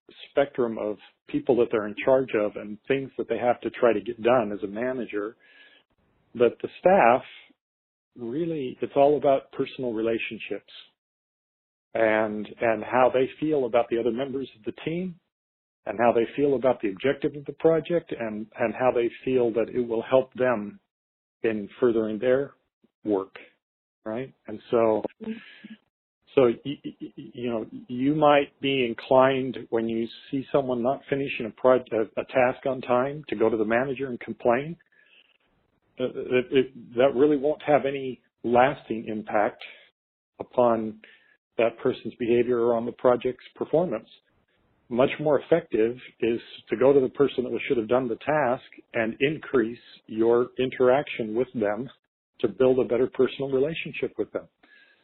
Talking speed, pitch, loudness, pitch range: 155 wpm, 125 Hz, -25 LUFS, 115-135 Hz